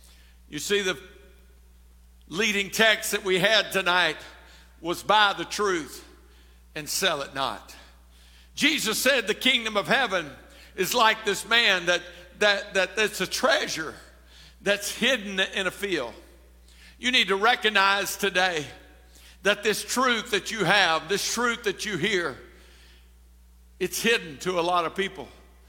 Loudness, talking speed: -24 LUFS, 140 wpm